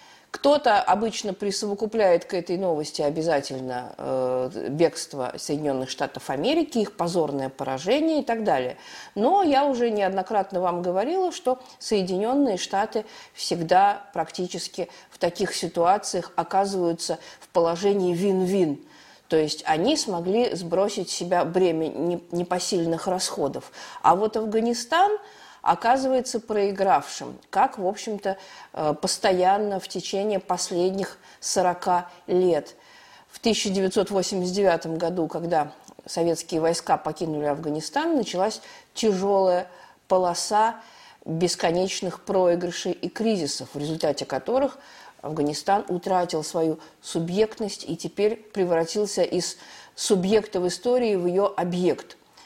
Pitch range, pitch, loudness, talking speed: 170-210 Hz, 185 Hz, -24 LUFS, 105 wpm